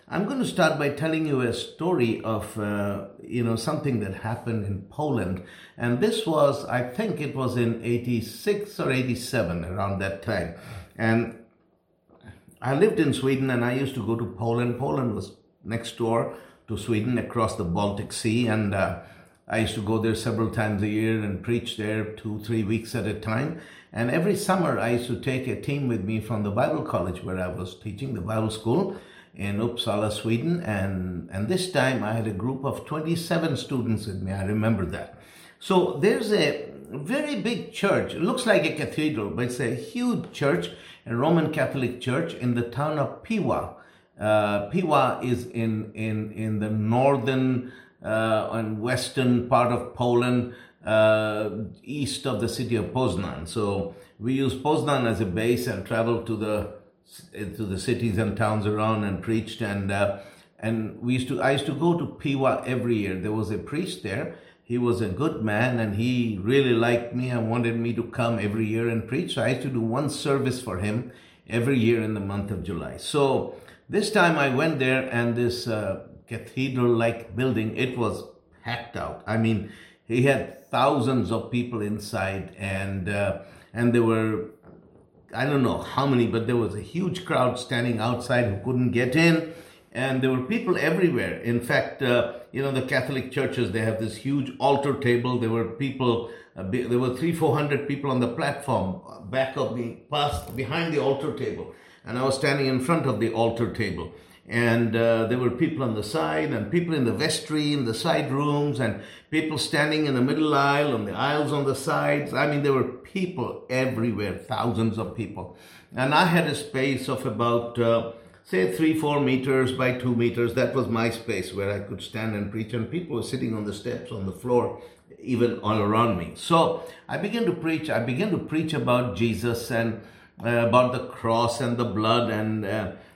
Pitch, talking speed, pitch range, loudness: 120 Hz, 195 wpm, 110-135 Hz, -26 LUFS